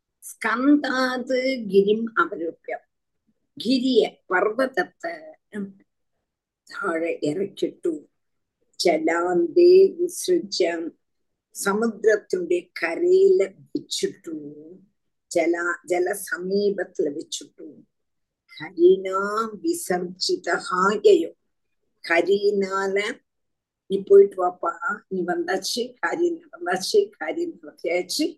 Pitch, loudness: 245 Hz, -22 LUFS